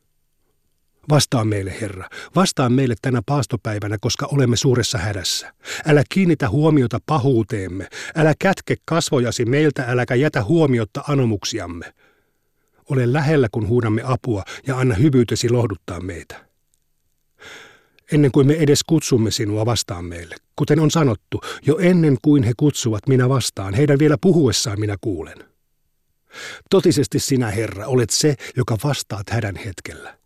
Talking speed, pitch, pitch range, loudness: 130 wpm, 125 Hz, 110-145 Hz, -19 LUFS